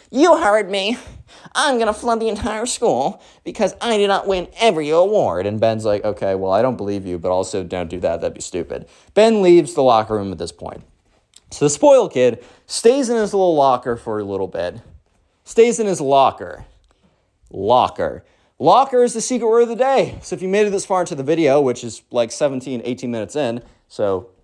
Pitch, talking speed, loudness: 160 Hz, 210 wpm, -18 LUFS